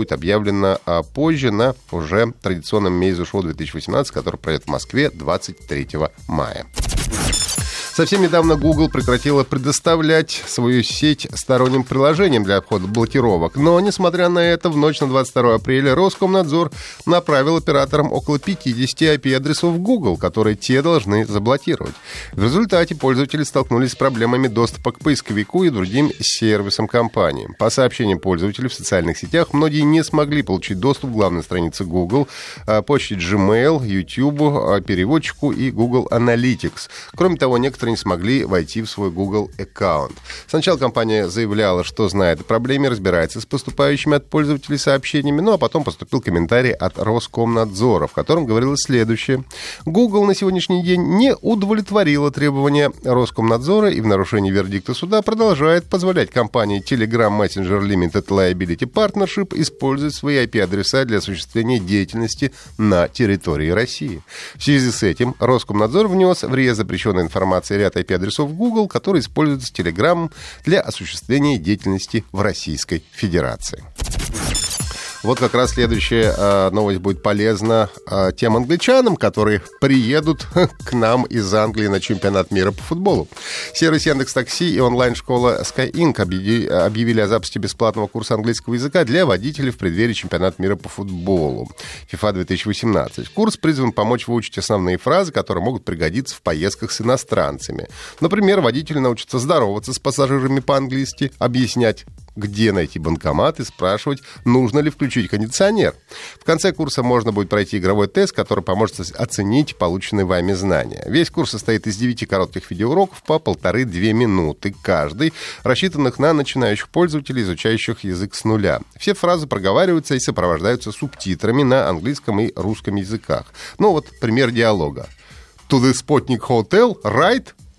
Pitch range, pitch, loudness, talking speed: 100-145 Hz, 120 Hz, -18 LUFS, 140 wpm